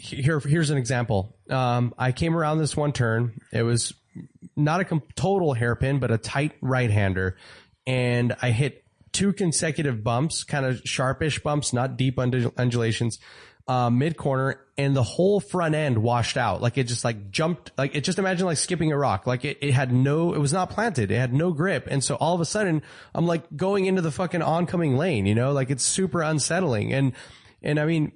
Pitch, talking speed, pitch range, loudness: 140 Hz, 200 wpm, 120-160 Hz, -24 LUFS